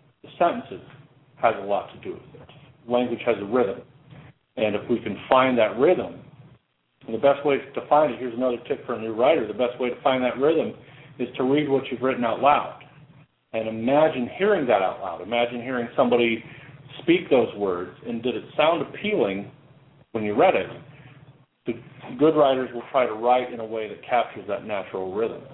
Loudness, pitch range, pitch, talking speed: -24 LUFS, 120-140 Hz, 125 Hz, 200 wpm